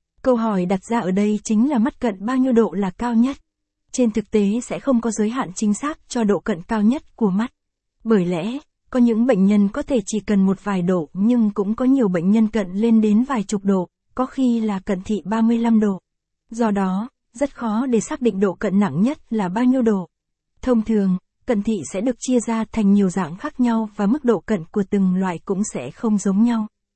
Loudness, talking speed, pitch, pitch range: -20 LUFS, 235 wpm, 220 Hz, 200-235 Hz